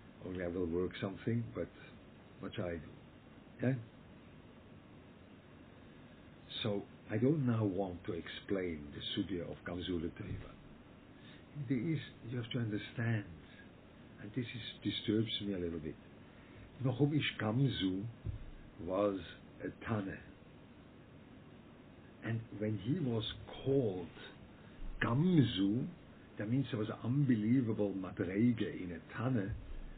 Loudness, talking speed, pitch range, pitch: -38 LUFS, 110 wpm, 95-120 Hz, 105 Hz